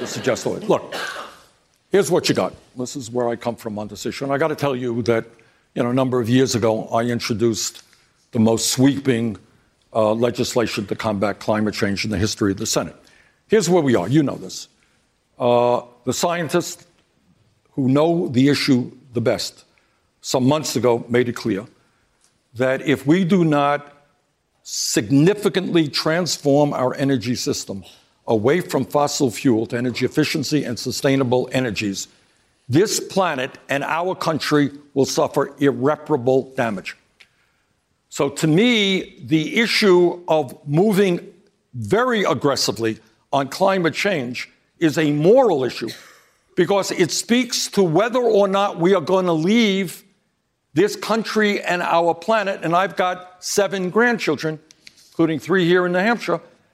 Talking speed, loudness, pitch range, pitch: 150 wpm, -19 LUFS, 125-180 Hz, 145 Hz